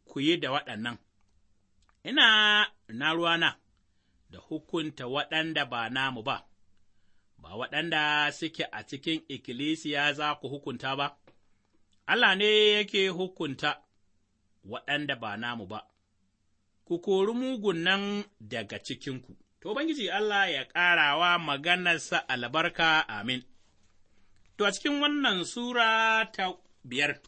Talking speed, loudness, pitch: 115 wpm, -27 LUFS, 145 Hz